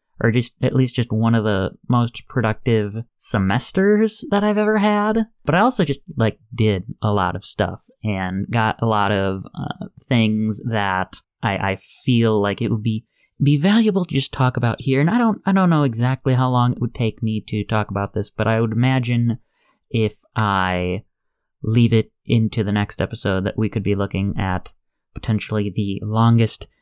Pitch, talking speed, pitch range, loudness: 115 Hz, 190 wpm, 105-130 Hz, -20 LUFS